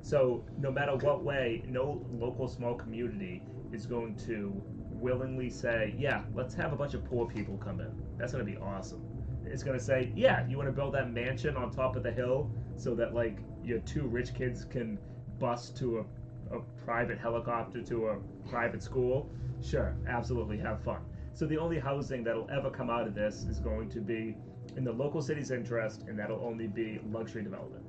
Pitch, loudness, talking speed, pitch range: 120 Hz, -35 LUFS, 200 wpm, 115-130 Hz